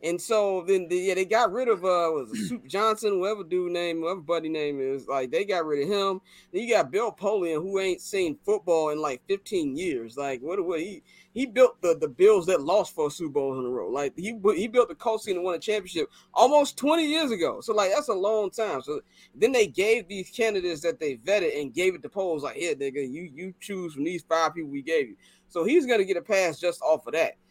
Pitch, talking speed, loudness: 205 Hz, 250 wpm, -26 LUFS